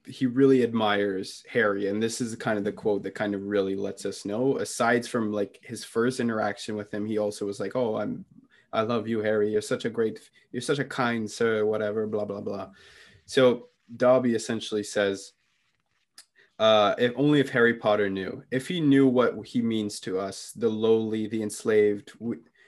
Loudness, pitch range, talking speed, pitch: -26 LUFS, 105-120 Hz, 195 wpm, 110 Hz